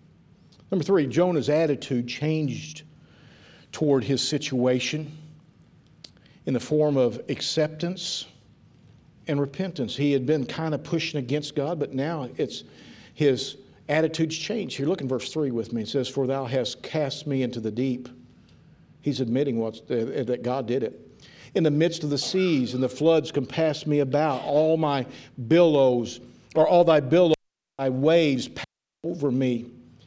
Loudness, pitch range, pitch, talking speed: -25 LUFS, 130-160 Hz, 145 Hz, 155 wpm